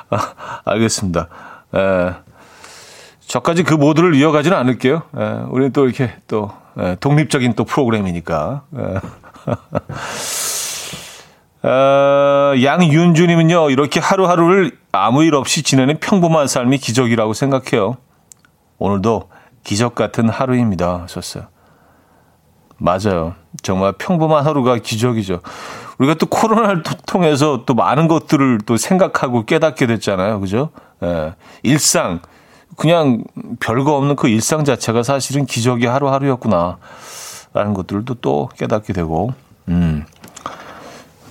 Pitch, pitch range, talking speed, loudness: 130 Hz, 110-155 Hz, 265 characters per minute, -16 LUFS